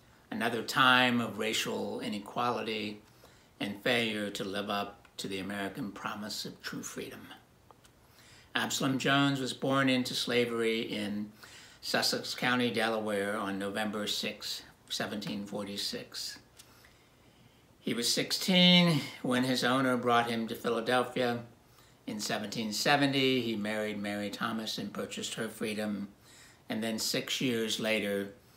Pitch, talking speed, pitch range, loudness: 115 Hz, 120 wpm, 105-125 Hz, -31 LUFS